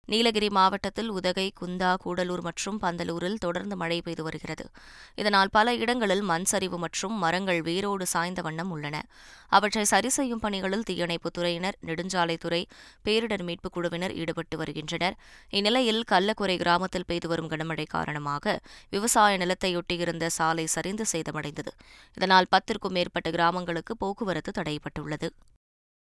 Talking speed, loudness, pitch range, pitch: 115 wpm, -27 LUFS, 165-200 Hz, 180 Hz